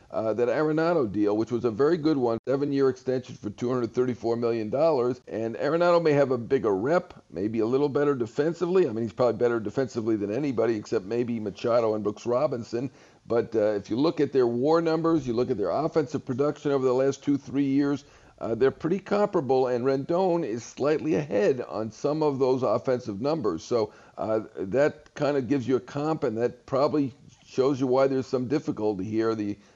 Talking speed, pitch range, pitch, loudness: 200 wpm, 115-145 Hz, 130 Hz, -26 LUFS